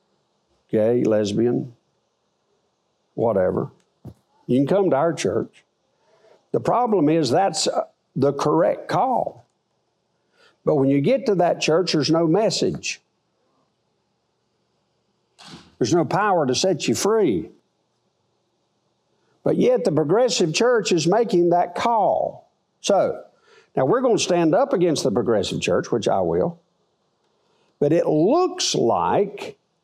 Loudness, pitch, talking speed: -20 LUFS, 180 Hz, 120 wpm